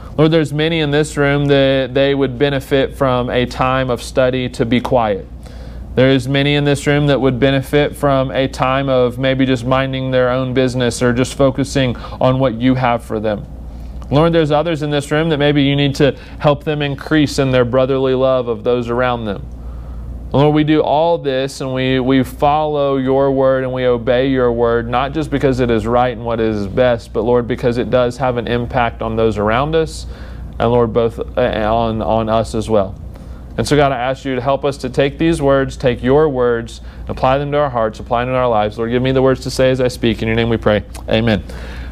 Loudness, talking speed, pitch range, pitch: -15 LUFS, 225 wpm, 115-140 Hz, 130 Hz